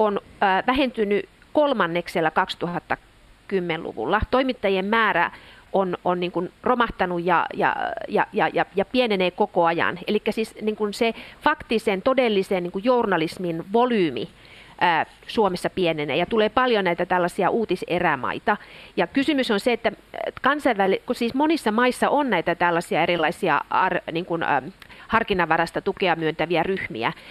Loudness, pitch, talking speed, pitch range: -23 LUFS, 200 Hz, 125 wpm, 175-235 Hz